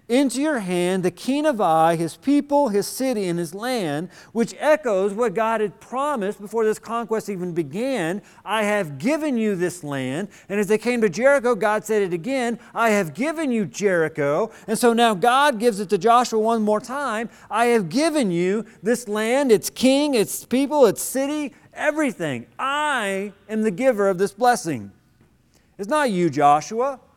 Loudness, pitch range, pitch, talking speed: -21 LUFS, 195-260 Hz, 220 Hz, 180 wpm